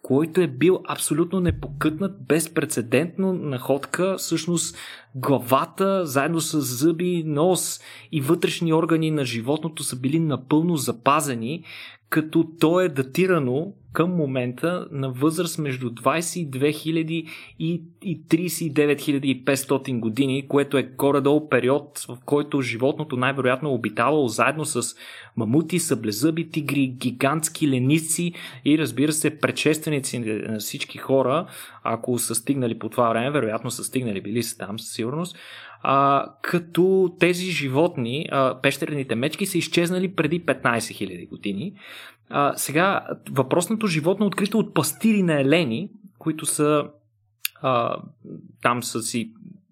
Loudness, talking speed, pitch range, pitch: -23 LUFS, 125 wpm, 130-165 Hz, 150 Hz